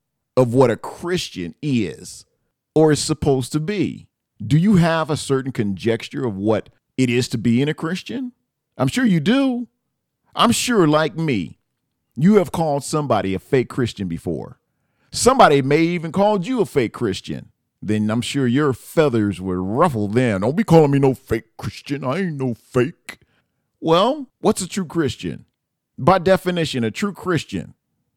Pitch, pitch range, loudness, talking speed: 140 Hz, 115-175 Hz, -19 LUFS, 165 wpm